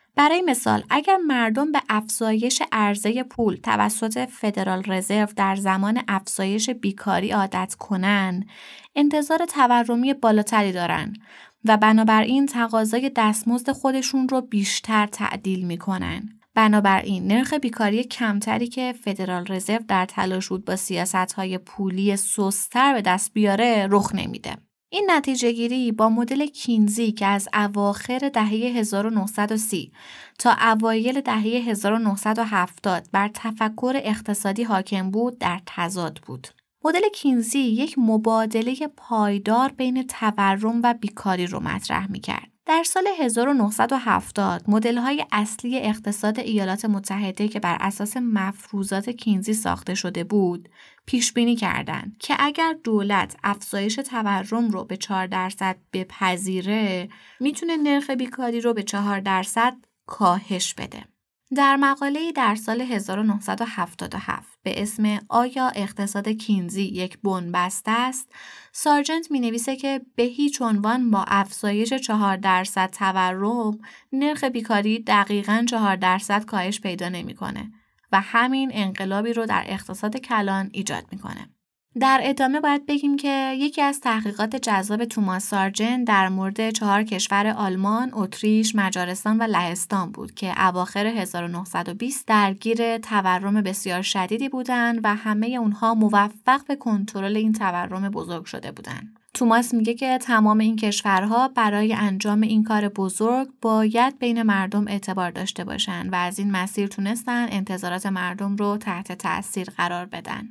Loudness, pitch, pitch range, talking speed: -22 LUFS, 215 Hz, 195-240 Hz, 130 wpm